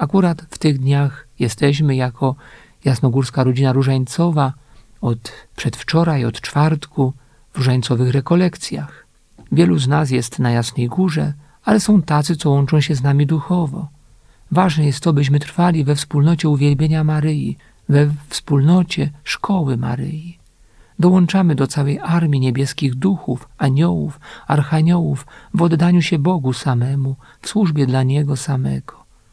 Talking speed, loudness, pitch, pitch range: 130 wpm, -17 LUFS, 145 Hz, 135-165 Hz